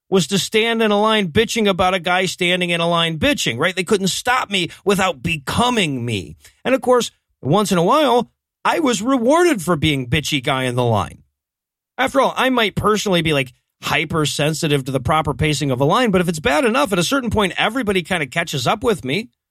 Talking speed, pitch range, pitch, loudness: 220 wpm, 150-220 Hz, 180 Hz, -18 LUFS